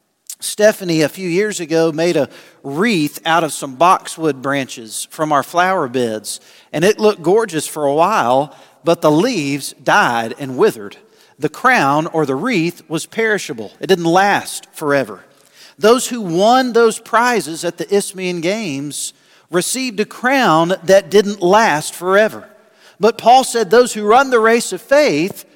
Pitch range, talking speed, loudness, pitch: 155-215 Hz, 155 wpm, -15 LUFS, 180 Hz